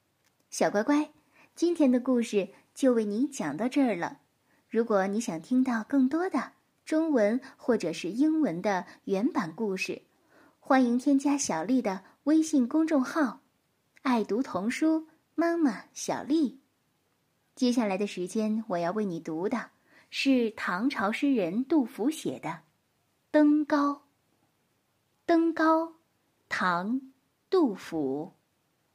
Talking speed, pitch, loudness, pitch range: 175 characters per minute, 260 Hz, -28 LUFS, 215-300 Hz